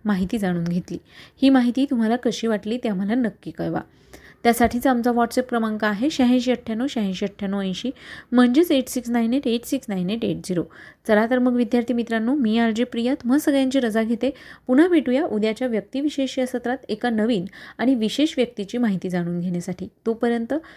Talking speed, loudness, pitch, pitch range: 175 wpm, -22 LUFS, 240 Hz, 215-255 Hz